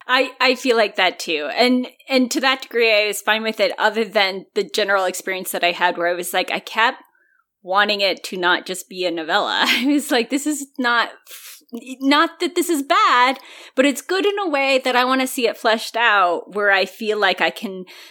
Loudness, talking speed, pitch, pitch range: -18 LUFS, 230 wpm, 225 Hz, 190-265 Hz